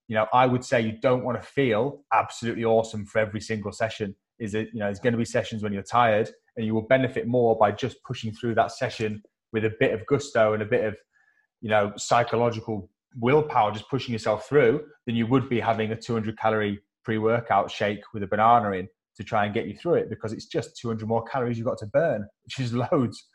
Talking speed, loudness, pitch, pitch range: 235 wpm, -25 LUFS, 115 Hz, 110-120 Hz